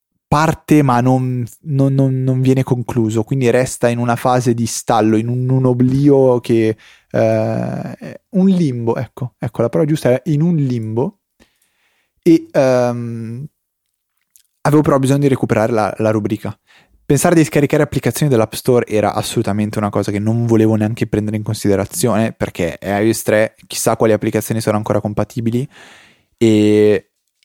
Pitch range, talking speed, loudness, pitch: 110-135 Hz, 145 wpm, -15 LUFS, 120 Hz